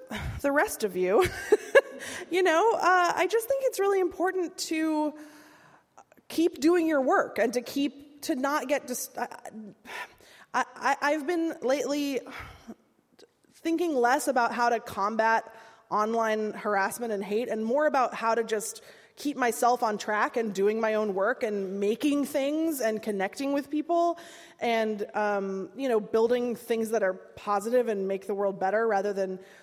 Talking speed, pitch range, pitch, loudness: 160 wpm, 215-310 Hz, 245 Hz, -27 LUFS